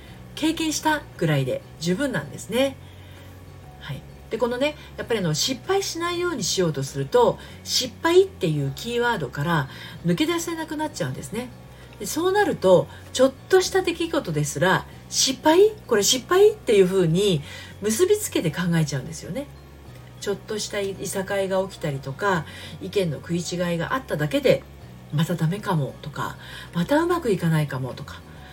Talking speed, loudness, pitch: 345 characters per minute, -23 LUFS, 190 Hz